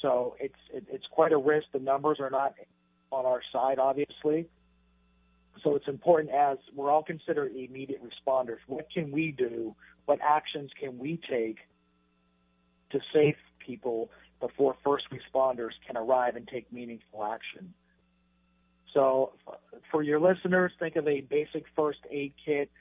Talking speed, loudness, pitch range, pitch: 145 wpm, -30 LUFS, 110-150 Hz, 135 Hz